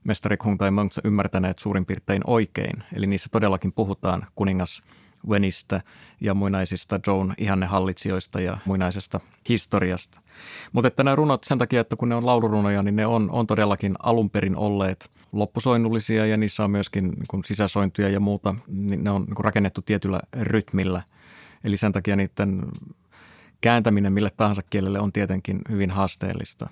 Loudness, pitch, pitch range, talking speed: -24 LUFS, 100 Hz, 95-110 Hz, 150 wpm